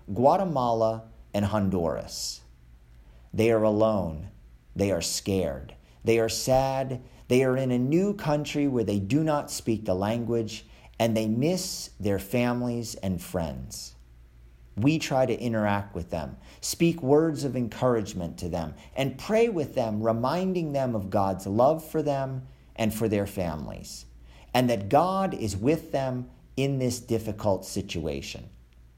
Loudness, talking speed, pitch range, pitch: -27 LUFS, 145 wpm, 90-130 Hz, 110 Hz